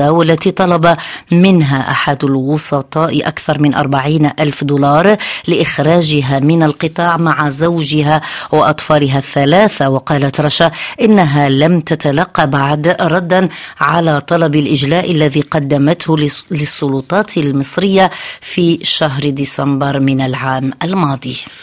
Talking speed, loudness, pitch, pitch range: 105 wpm, -12 LUFS, 155 Hz, 145-170 Hz